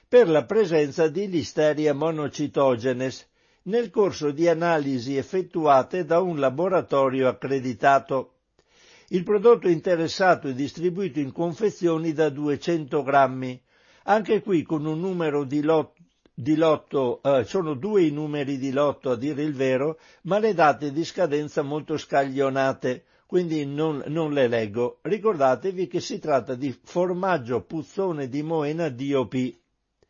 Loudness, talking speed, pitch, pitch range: -24 LUFS, 135 wpm, 155 Hz, 140-175 Hz